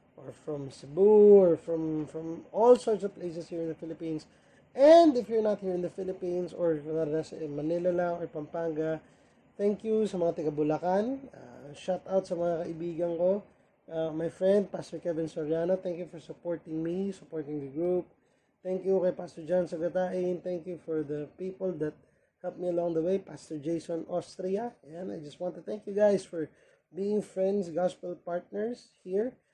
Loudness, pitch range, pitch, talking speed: -30 LUFS, 160-190 Hz, 175 Hz, 175 wpm